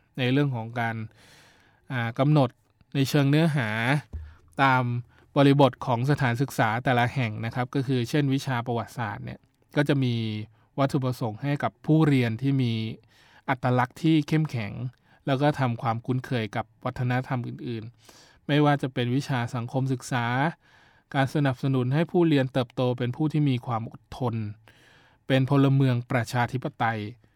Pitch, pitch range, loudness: 130 Hz, 115-140 Hz, -26 LUFS